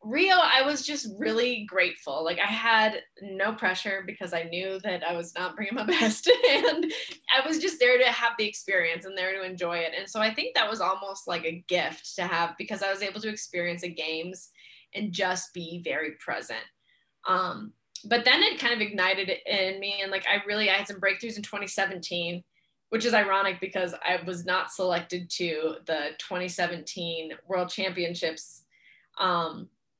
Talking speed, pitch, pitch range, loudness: 185 wpm, 190 Hz, 175-215 Hz, -27 LUFS